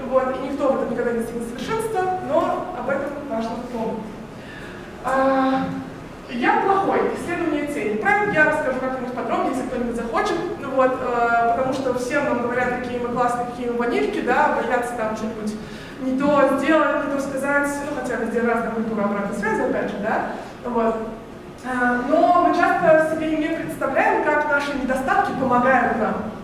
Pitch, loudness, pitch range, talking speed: 260 Hz, -21 LUFS, 240-300 Hz, 165 wpm